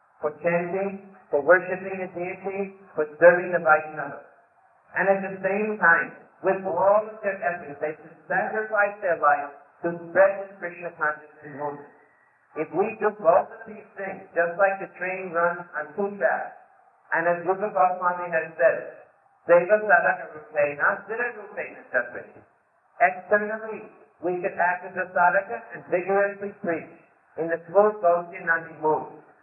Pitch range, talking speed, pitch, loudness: 165-195 Hz, 150 wpm, 180 Hz, -24 LUFS